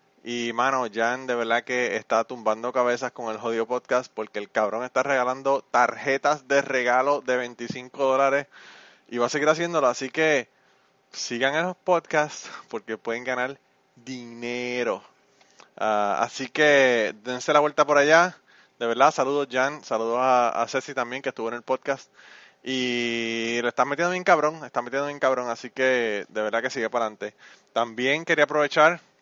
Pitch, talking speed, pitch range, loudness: 125 Hz, 170 wpm, 120-145 Hz, -24 LUFS